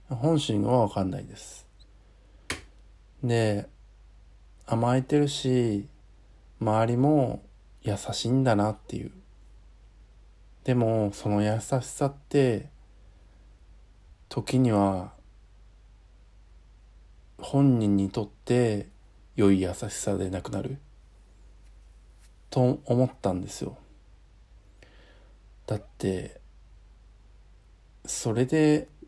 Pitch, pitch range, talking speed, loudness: 105 Hz, 95-125 Hz, 145 characters per minute, -27 LUFS